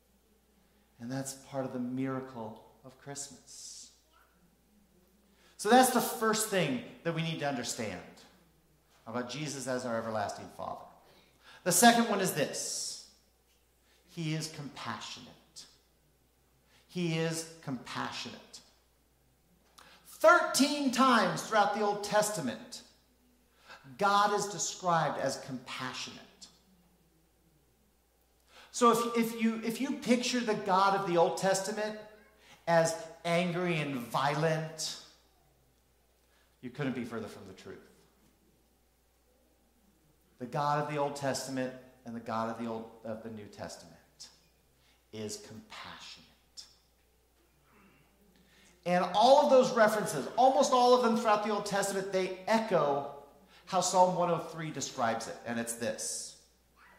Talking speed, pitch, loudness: 115 wpm, 160 Hz, -31 LUFS